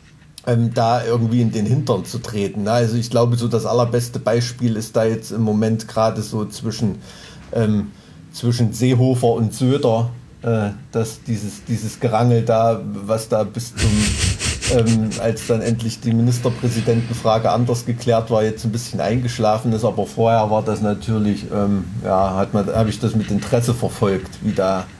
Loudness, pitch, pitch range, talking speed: -19 LUFS, 115 Hz, 105-120 Hz, 160 wpm